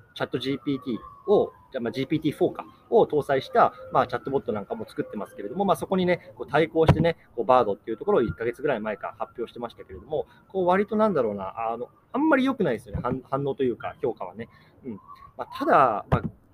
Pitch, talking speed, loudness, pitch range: 140 Hz, 480 characters per minute, -26 LUFS, 125-180 Hz